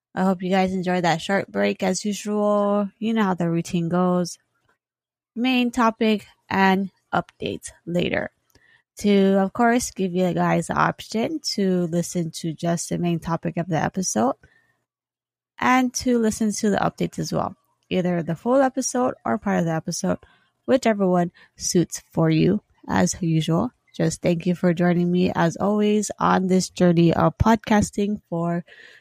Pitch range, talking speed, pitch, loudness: 175-210 Hz, 160 wpm, 185 Hz, -22 LUFS